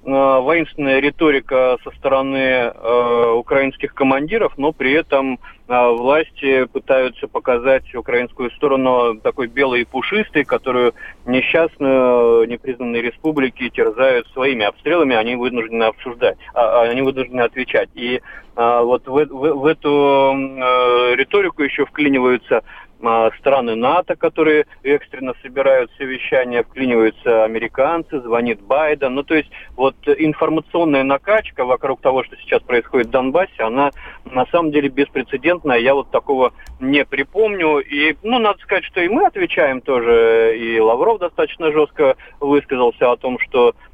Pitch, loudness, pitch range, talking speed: 135 Hz, -16 LUFS, 125-160 Hz, 130 wpm